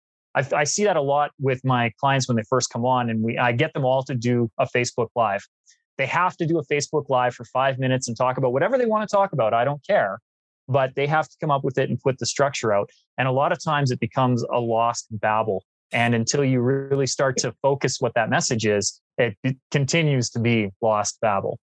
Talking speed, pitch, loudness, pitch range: 240 wpm, 130 Hz, -22 LUFS, 120-145 Hz